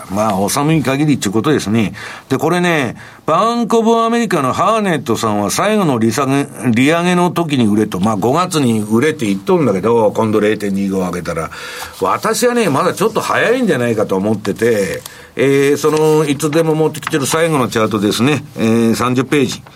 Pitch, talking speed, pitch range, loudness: 135 Hz, 380 characters per minute, 110-160 Hz, -14 LUFS